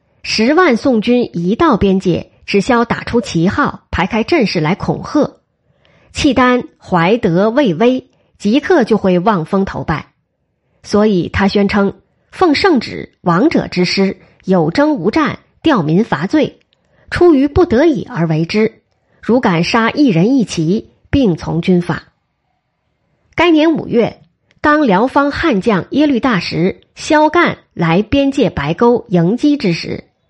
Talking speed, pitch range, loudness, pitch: 195 characters per minute, 180-285 Hz, -13 LUFS, 220 Hz